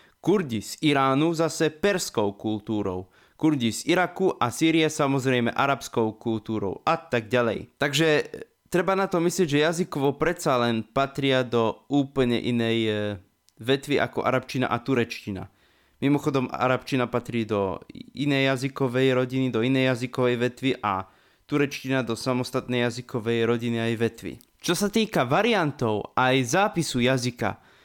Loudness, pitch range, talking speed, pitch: -25 LUFS, 115-150 Hz, 135 wpm, 130 Hz